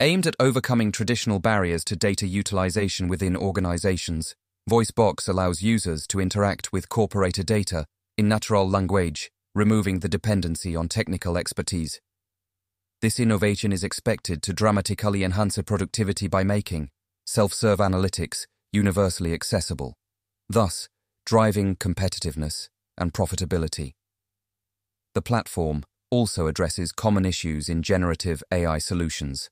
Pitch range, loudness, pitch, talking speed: 90-105 Hz, -24 LUFS, 95 Hz, 115 wpm